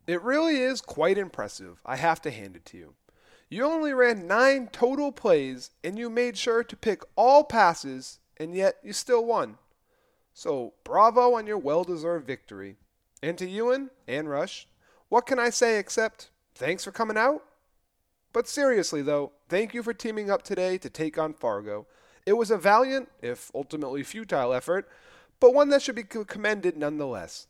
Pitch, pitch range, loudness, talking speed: 215 Hz, 155-250 Hz, -26 LUFS, 175 wpm